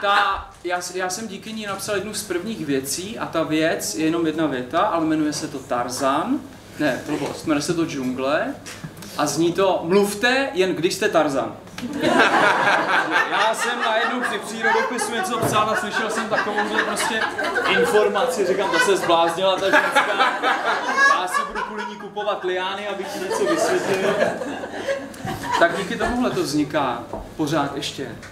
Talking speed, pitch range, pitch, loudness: 160 wpm, 165-220 Hz, 190 Hz, -21 LUFS